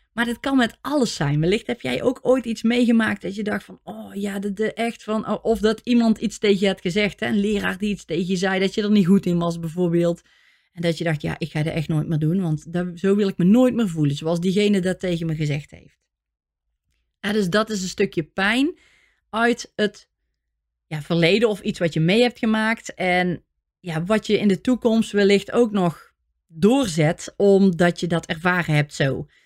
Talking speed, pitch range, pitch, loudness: 225 wpm, 170-220 Hz, 195 Hz, -21 LUFS